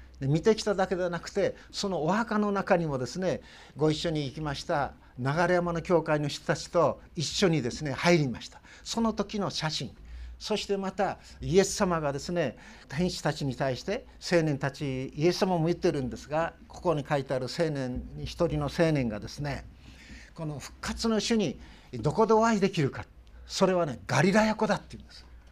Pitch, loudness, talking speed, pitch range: 165 Hz, -29 LUFS, 355 characters per minute, 140-190 Hz